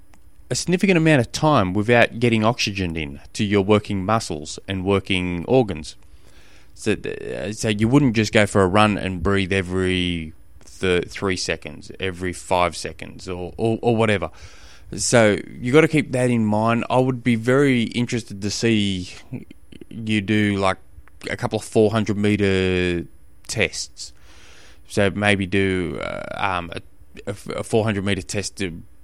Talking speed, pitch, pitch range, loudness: 150 wpm, 100 Hz, 90-115 Hz, -21 LUFS